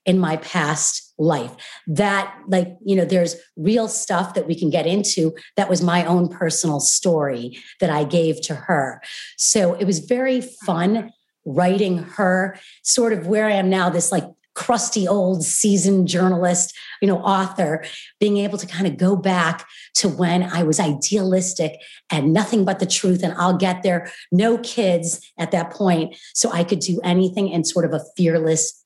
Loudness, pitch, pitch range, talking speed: -19 LUFS, 180 Hz, 165-195 Hz, 175 wpm